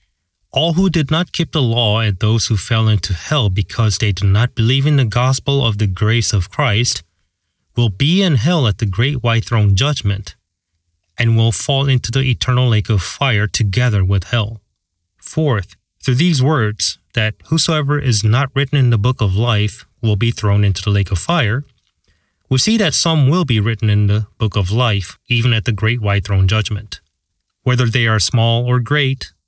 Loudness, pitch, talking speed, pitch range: -16 LUFS, 115 Hz, 195 wpm, 100-130 Hz